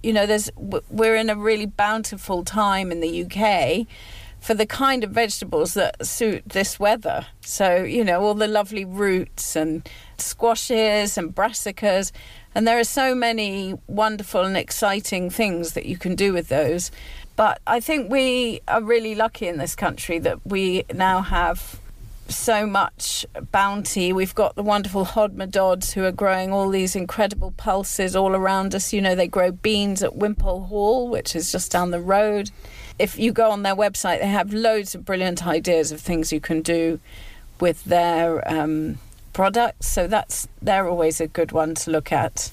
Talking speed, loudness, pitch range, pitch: 175 wpm, -22 LUFS, 175-215 Hz, 195 Hz